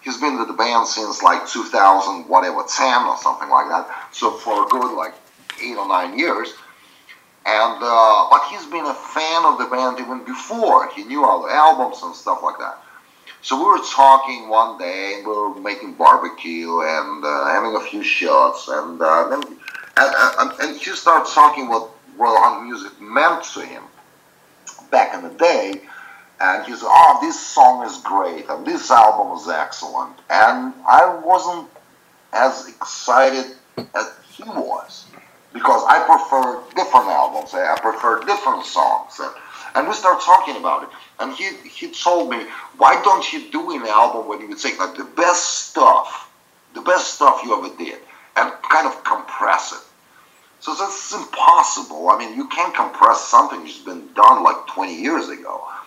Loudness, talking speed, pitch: -16 LUFS, 175 wpm, 175 Hz